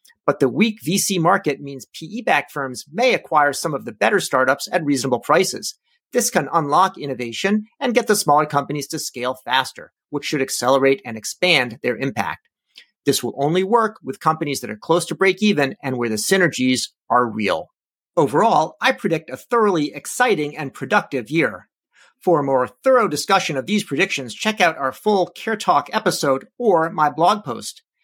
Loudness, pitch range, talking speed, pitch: -19 LUFS, 135-195 Hz, 180 wpm, 155 Hz